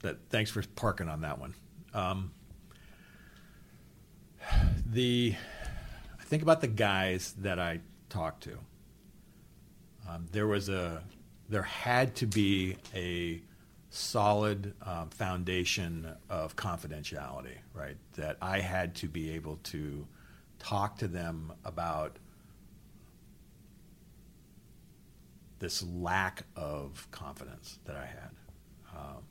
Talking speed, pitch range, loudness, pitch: 105 wpm, 85-105 Hz, -34 LUFS, 95 Hz